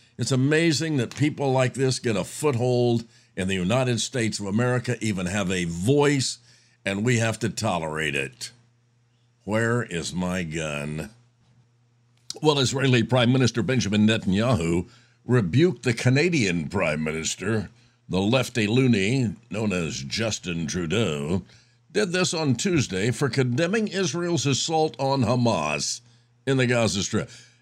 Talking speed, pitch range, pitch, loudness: 135 wpm, 105-130 Hz, 120 Hz, -24 LUFS